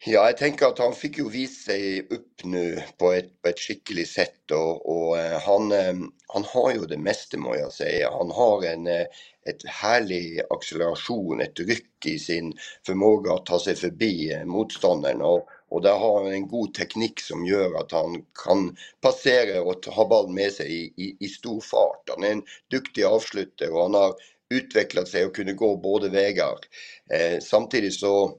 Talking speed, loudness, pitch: 180 wpm, -24 LUFS, 100 Hz